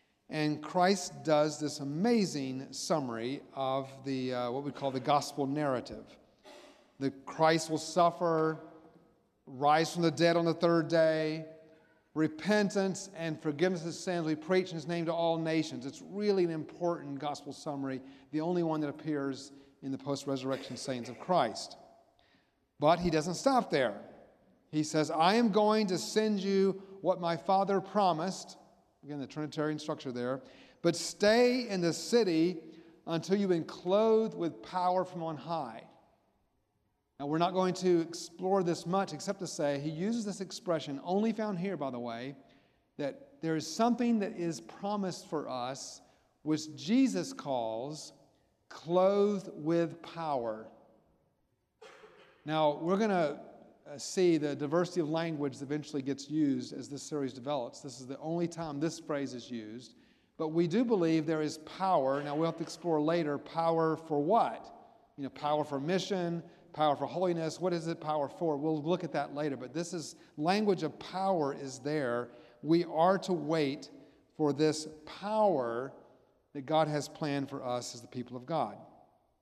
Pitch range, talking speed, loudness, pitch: 145-180 Hz, 160 wpm, -32 LUFS, 160 Hz